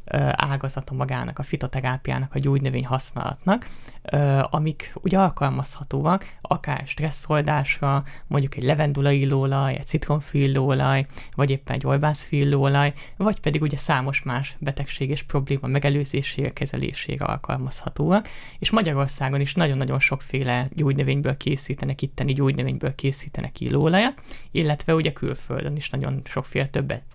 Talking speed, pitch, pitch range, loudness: 115 wpm, 140 Hz, 135-150 Hz, -24 LUFS